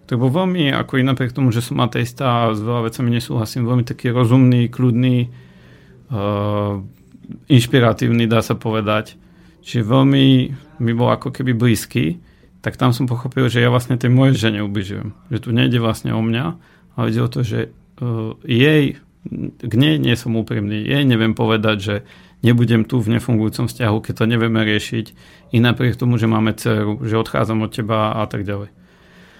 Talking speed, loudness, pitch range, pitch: 175 wpm, -18 LUFS, 110-130 Hz, 120 Hz